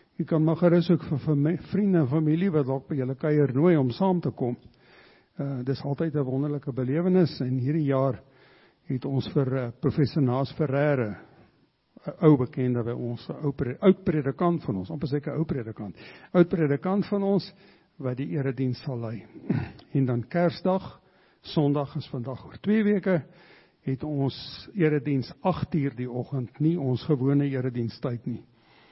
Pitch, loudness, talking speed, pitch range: 145 Hz, -26 LUFS, 160 wpm, 130-165 Hz